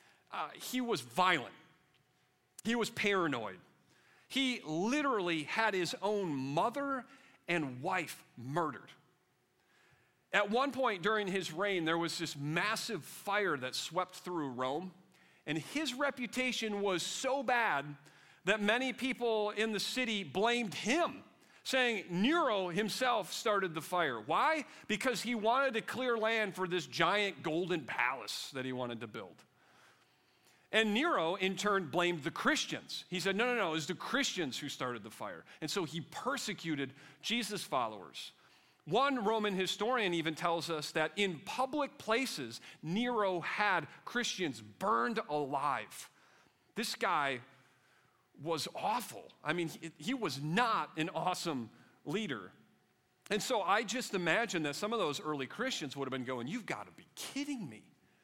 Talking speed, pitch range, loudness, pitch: 145 wpm, 160-235 Hz, -35 LUFS, 190 Hz